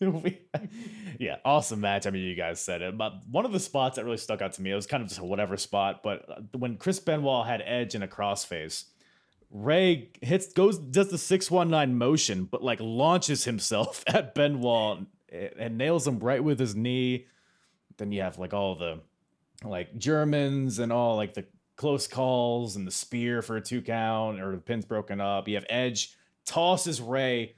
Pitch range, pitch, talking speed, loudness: 100-145 Hz, 120 Hz, 190 wpm, -28 LUFS